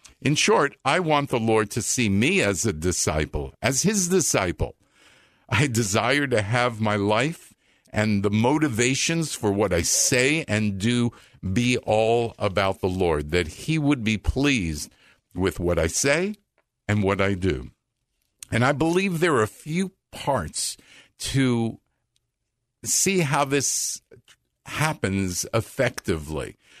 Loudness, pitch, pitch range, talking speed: -23 LUFS, 120 Hz, 100-145 Hz, 140 wpm